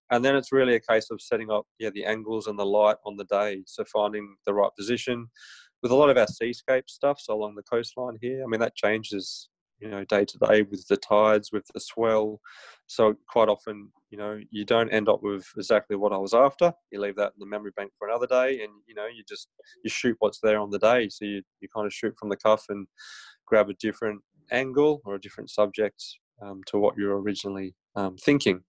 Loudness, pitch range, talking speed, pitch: -26 LUFS, 100-115 Hz, 235 wpm, 105 Hz